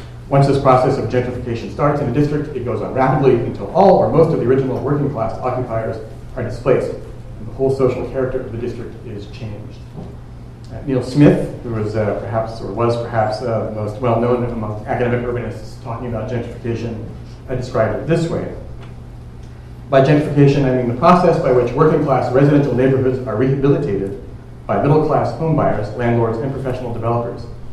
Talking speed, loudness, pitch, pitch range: 170 wpm, -17 LUFS, 120 Hz, 115-135 Hz